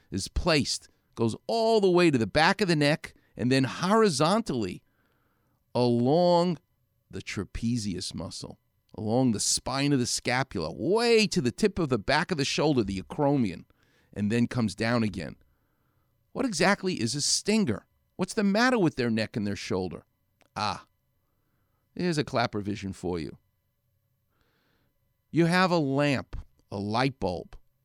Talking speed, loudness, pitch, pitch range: 150 wpm, -27 LUFS, 125 Hz, 110-175 Hz